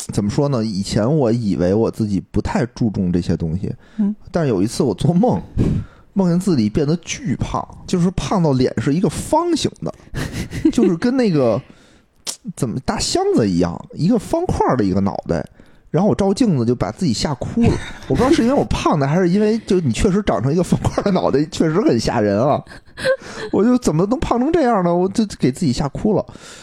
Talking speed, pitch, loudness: 300 characters per minute, 180 Hz, -18 LUFS